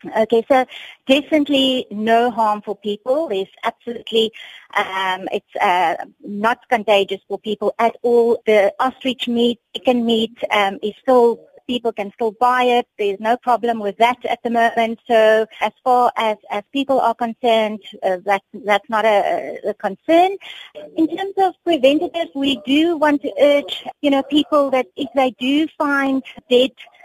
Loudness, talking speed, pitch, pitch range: -18 LUFS, 165 wpm, 240 Hz, 215-275 Hz